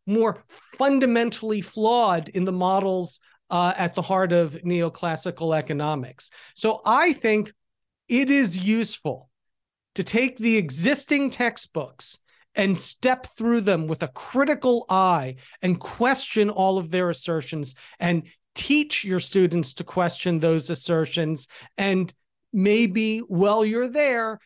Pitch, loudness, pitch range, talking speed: 190 Hz, -23 LUFS, 170-230 Hz, 125 wpm